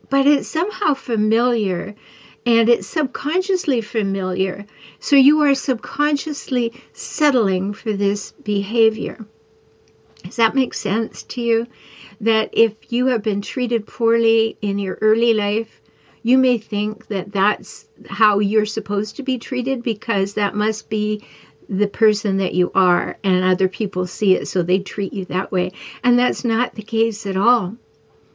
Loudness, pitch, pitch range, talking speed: -19 LUFS, 220 Hz, 200-245 Hz, 150 wpm